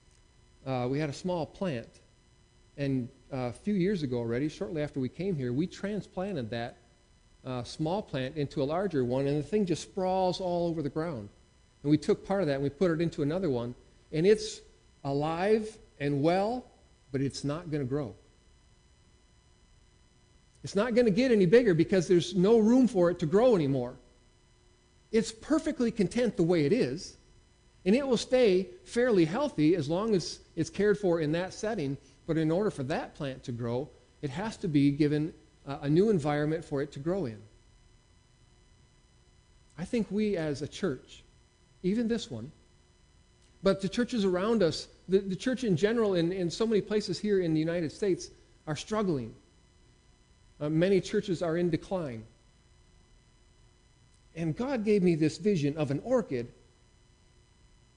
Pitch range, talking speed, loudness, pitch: 130-195 Hz, 170 wpm, -30 LUFS, 160 Hz